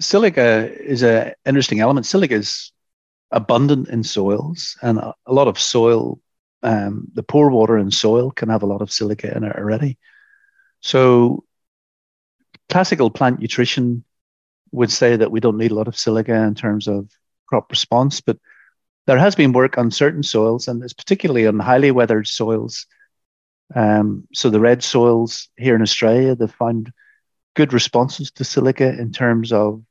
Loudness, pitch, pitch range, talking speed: -17 LUFS, 120 Hz, 110-135 Hz, 160 wpm